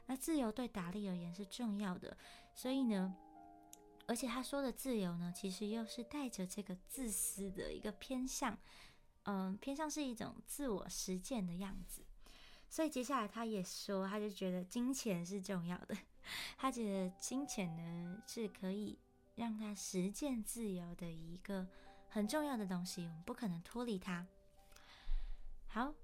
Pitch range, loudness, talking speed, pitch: 185-245 Hz, -44 LUFS, 235 characters per minute, 205 Hz